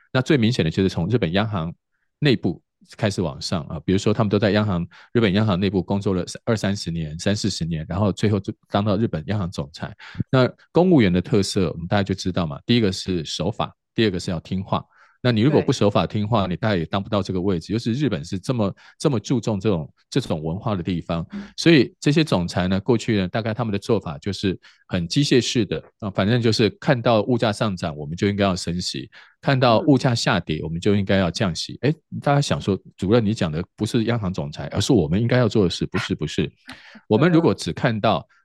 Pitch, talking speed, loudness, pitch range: 105 Hz, 345 characters per minute, -22 LUFS, 95-115 Hz